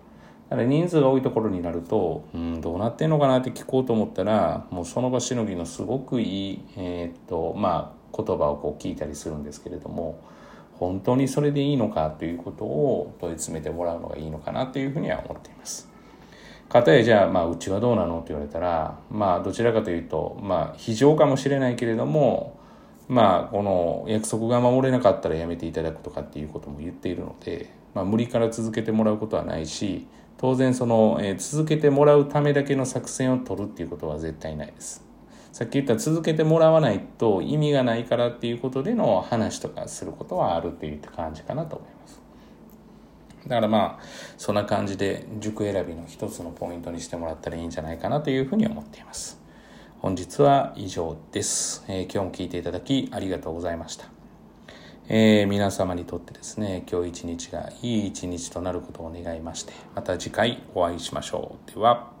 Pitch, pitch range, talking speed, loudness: 105 Hz, 85-130 Hz, 415 characters per minute, -25 LUFS